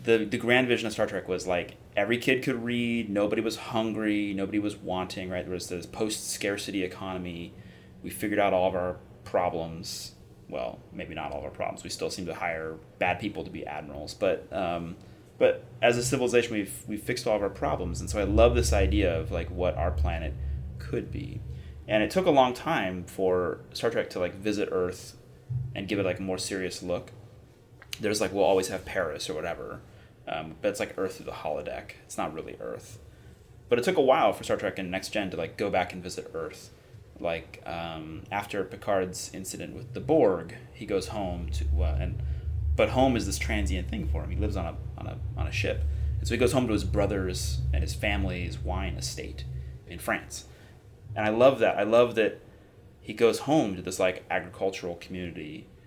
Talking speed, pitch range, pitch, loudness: 210 wpm, 85-110 Hz, 95 Hz, -29 LUFS